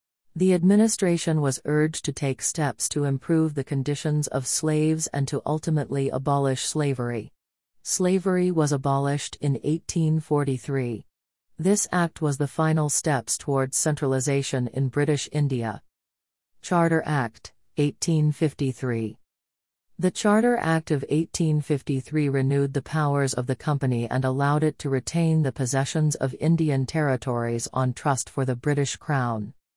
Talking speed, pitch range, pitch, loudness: 130 wpm, 130-155 Hz, 140 Hz, -24 LUFS